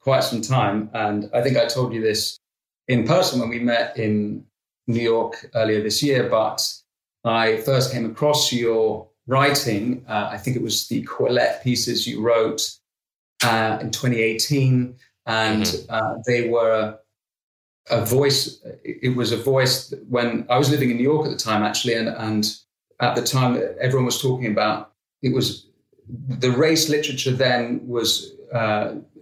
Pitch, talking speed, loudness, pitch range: 120 Hz, 165 wpm, -21 LUFS, 110-130 Hz